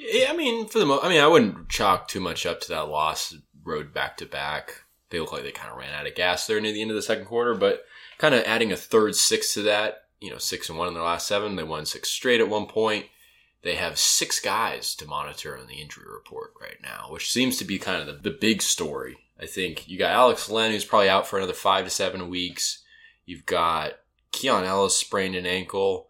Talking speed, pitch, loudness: 250 wpm, 110 Hz, -24 LUFS